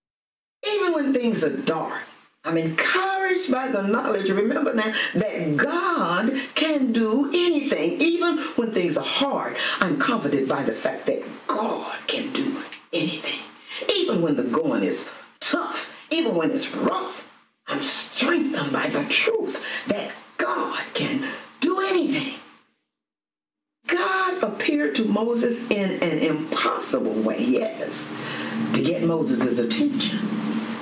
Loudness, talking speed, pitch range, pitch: -23 LUFS, 125 wpm, 220-330 Hz, 275 Hz